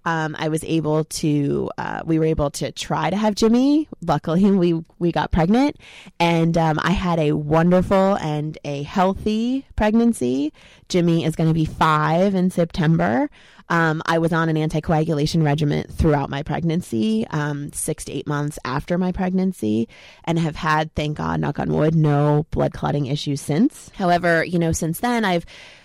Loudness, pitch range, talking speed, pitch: -20 LUFS, 150-180 Hz, 170 wpm, 160 Hz